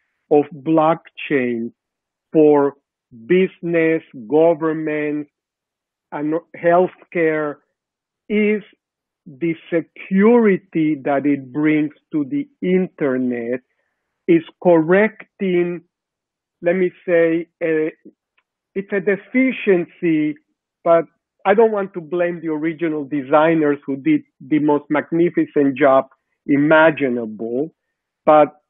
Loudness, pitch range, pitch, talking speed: -18 LUFS, 150-180 Hz, 160 Hz, 90 wpm